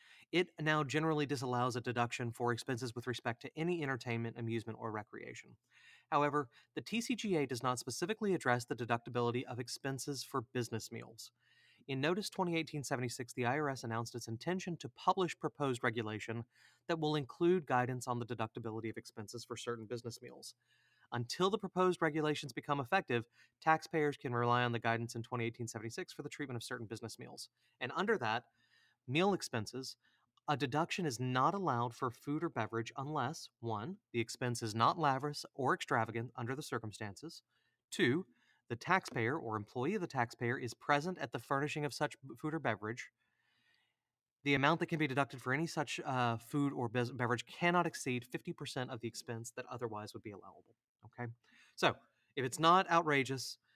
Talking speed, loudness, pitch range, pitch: 170 wpm, -37 LUFS, 120-150 Hz, 125 Hz